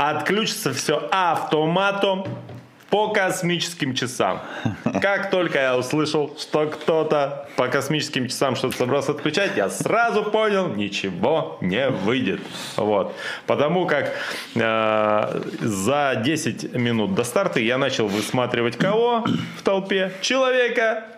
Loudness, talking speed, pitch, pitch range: -22 LUFS, 115 wpm, 155 Hz, 125-195 Hz